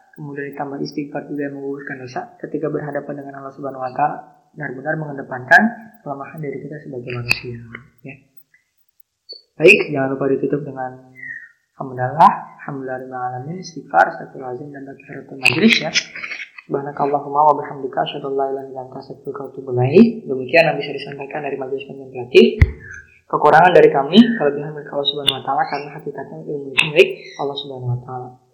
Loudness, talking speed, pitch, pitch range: -17 LUFS, 160 wpm, 140 Hz, 130-145 Hz